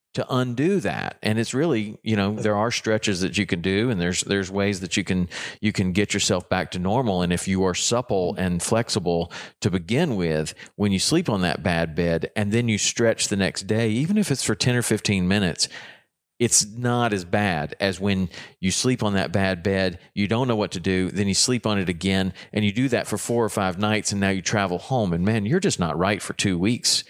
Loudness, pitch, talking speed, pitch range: -23 LUFS, 100 Hz, 240 wpm, 95-110 Hz